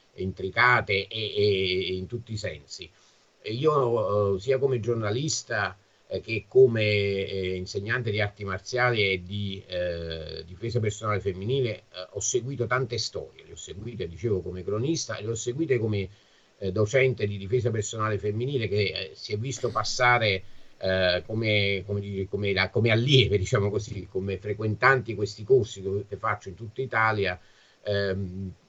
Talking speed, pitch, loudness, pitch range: 160 wpm, 105 Hz, -26 LUFS, 95-120 Hz